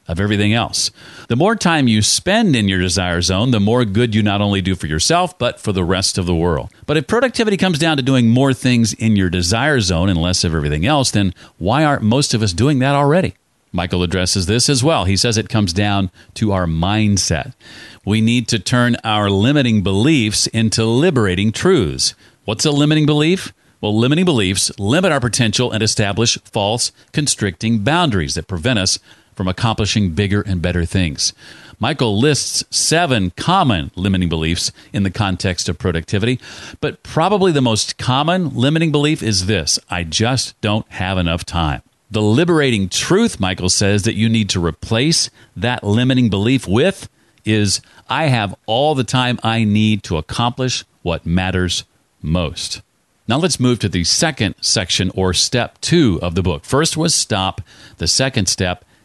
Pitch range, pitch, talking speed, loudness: 95-130 Hz, 110 Hz, 175 wpm, -16 LUFS